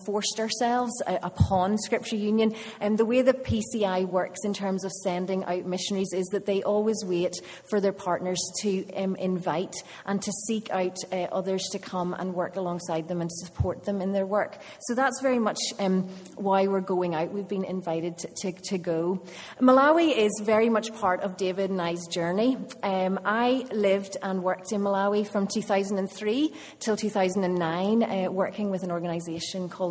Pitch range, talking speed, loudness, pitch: 185-210 Hz, 180 wpm, -27 LUFS, 195 Hz